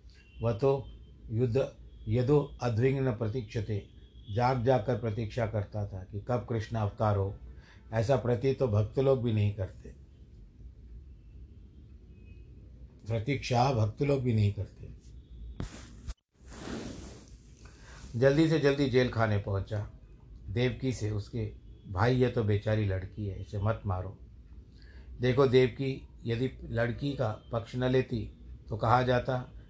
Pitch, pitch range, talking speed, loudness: 115 Hz, 100-125 Hz, 125 wpm, -31 LUFS